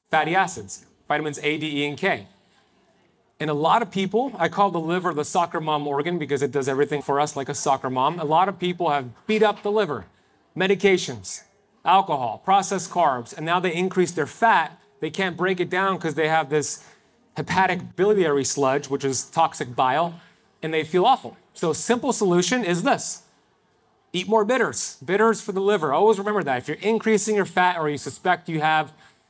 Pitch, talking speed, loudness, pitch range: 170 Hz, 195 wpm, -22 LUFS, 150-195 Hz